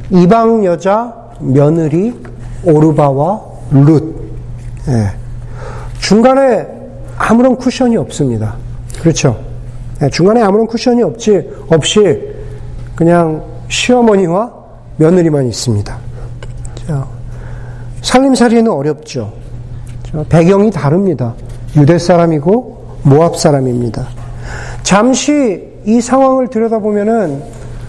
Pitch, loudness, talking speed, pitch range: 145 Hz, -11 LUFS, 210 characters per minute, 120-205 Hz